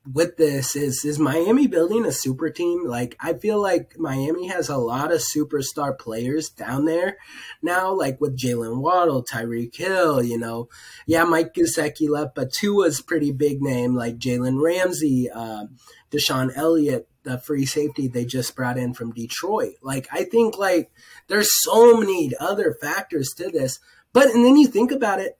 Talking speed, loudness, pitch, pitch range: 175 wpm, -21 LUFS, 150 Hz, 130-175 Hz